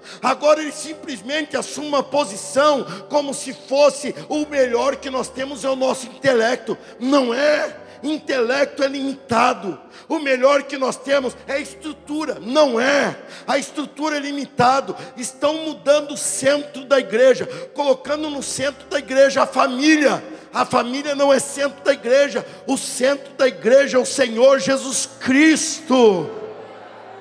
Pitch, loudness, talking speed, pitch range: 275 Hz, -19 LUFS, 145 wpm, 260-290 Hz